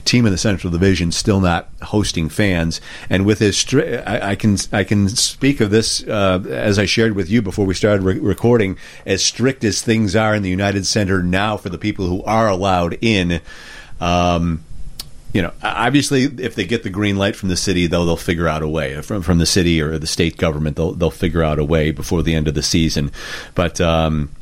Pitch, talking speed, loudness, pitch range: 95 Hz, 220 wpm, -17 LUFS, 85-105 Hz